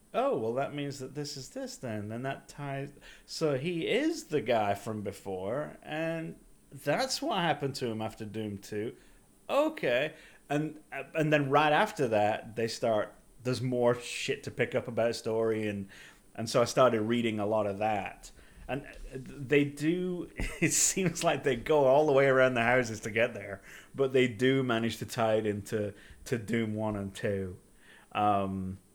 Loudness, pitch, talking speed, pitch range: -30 LUFS, 125 Hz, 180 wpm, 110-145 Hz